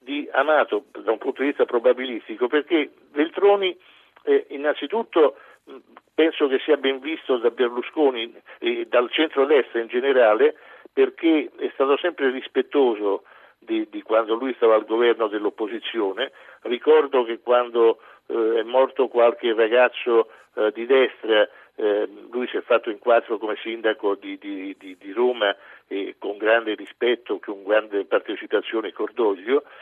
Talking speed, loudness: 140 wpm, -22 LUFS